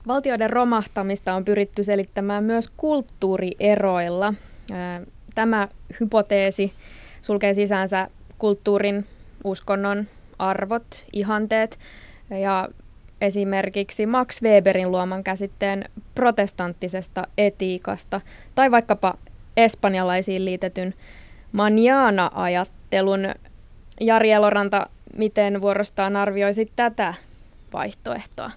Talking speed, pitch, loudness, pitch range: 75 wpm, 200 Hz, -22 LUFS, 190-215 Hz